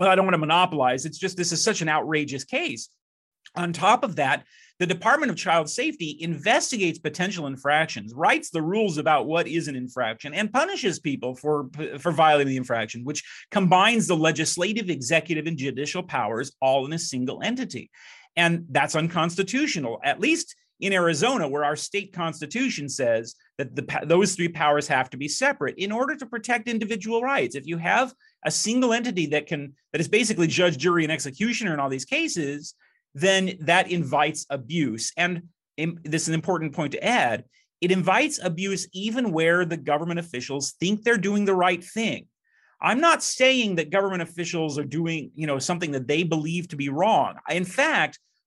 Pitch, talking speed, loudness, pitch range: 170 Hz, 180 wpm, -24 LUFS, 150-195 Hz